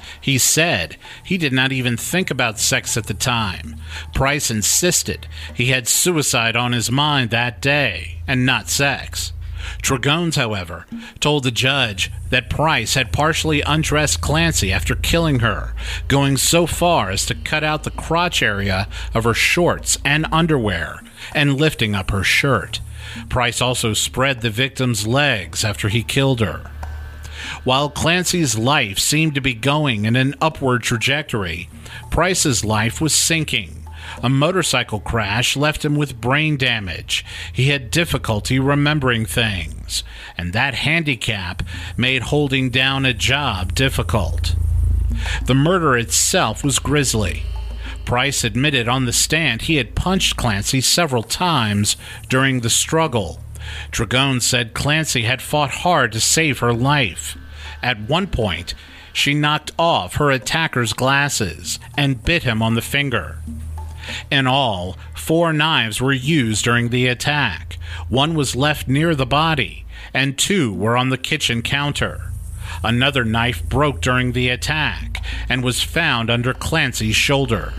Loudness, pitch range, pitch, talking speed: -18 LUFS, 95-140 Hz, 120 Hz, 140 wpm